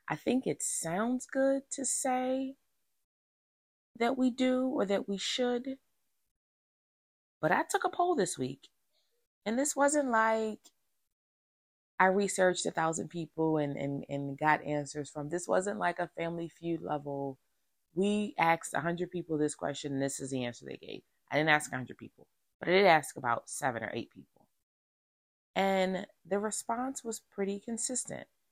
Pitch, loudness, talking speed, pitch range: 190 Hz, -32 LUFS, 165 wpm, 155-250 Hz